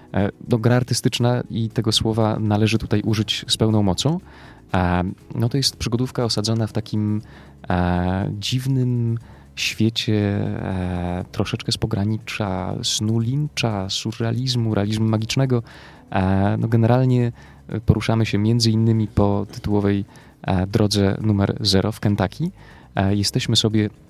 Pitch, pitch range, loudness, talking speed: 110 Hz, 100-120 Hz, -21 LUFS, 110 wpm